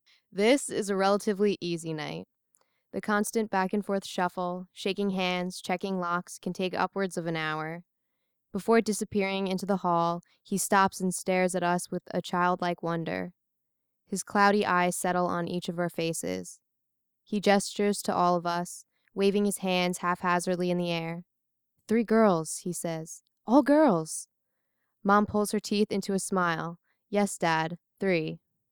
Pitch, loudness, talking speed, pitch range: 185 Hz, -28 LUFS, 155 wpm, 175-200 Hz